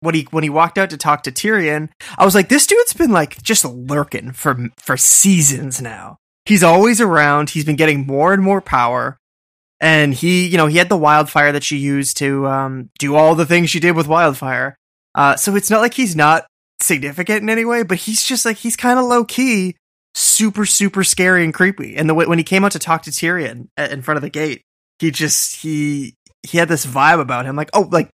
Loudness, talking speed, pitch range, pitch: -14 LUFS, 230 wpm, 145-195 Hz, 165 Hz